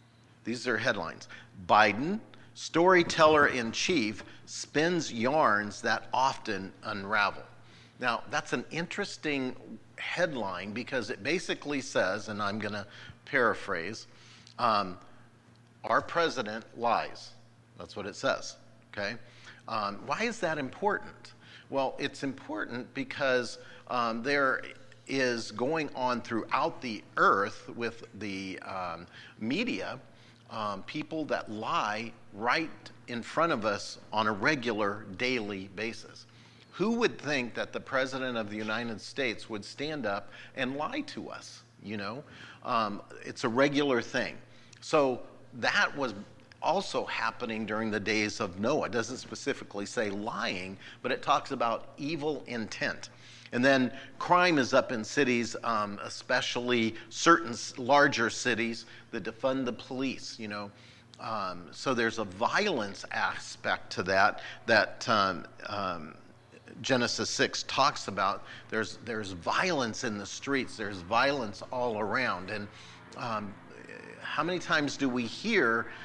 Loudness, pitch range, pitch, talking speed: -31 LUFS, 110-135 Hz, 120 Hz, 130 wpm